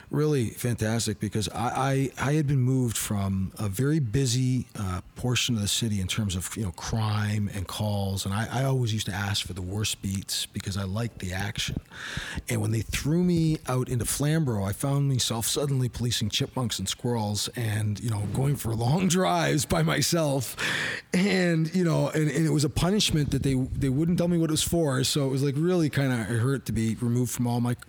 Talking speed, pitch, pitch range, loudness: 215 wpm, 125 Hz, 105-145 Hz, -27 LUFS